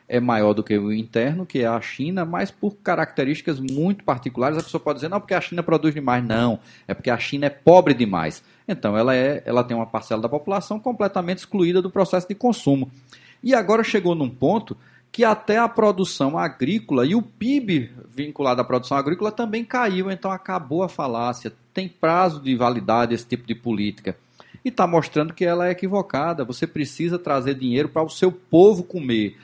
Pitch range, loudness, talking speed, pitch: 125-185 Hz, -21 LUFS, 190 wpm, 155 Hz